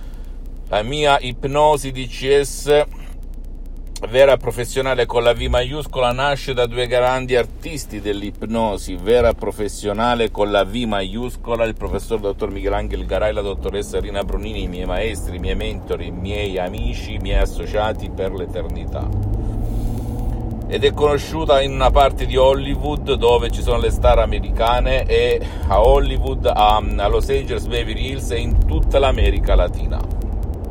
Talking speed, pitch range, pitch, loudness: 145 wpm, 95-125 Hz, 105 Hz, -19 LUFS